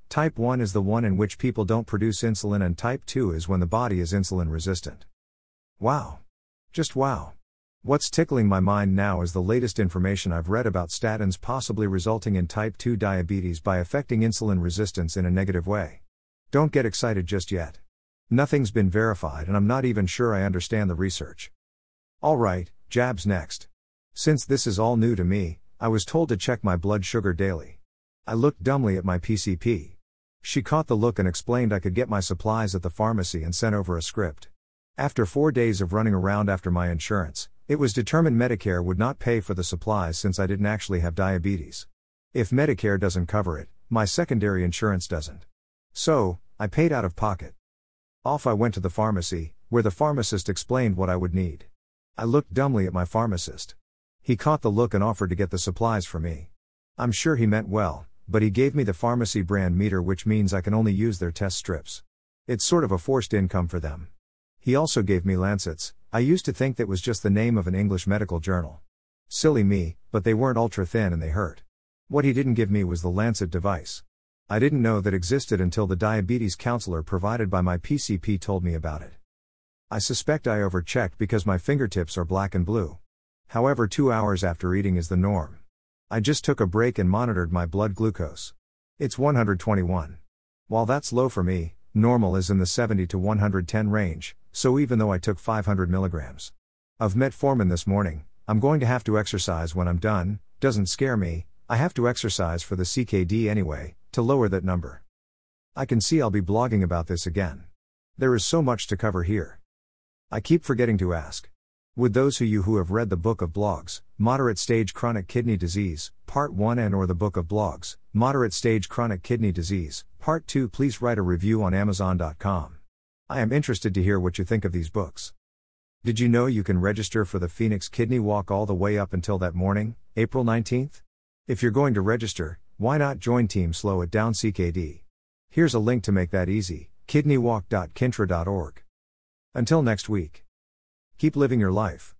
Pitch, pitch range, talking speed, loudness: 100 Hz, 90-115 Hz, 195 wpm, -25 LUFS